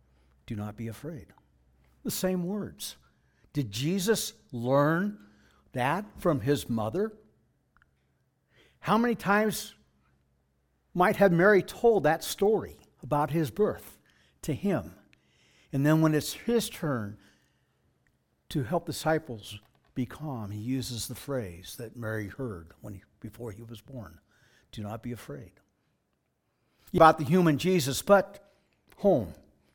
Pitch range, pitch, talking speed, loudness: 100-165 Hz, 125 Hz, 125 wpm, -28 LUFS